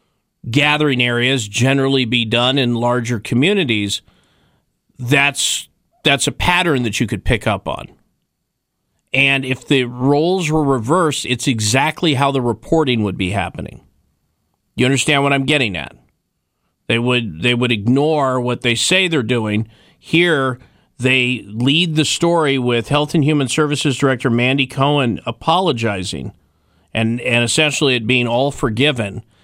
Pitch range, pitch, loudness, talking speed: 115-145 Hz, 130 Hz, -16 LUFS, 140 wpm